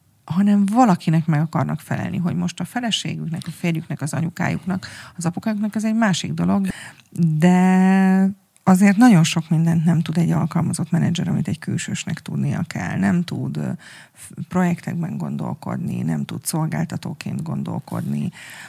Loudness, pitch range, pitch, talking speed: -20 LUFS, 165-190 Hz, 175 Hz, 135 wpm